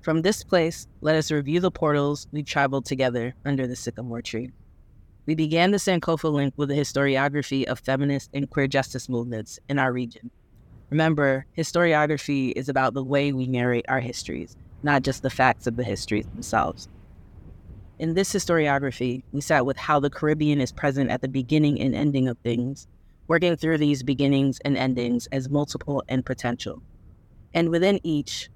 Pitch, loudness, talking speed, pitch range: 135 Hz, -24 LUFS, 170 wpm, 120-150 Hz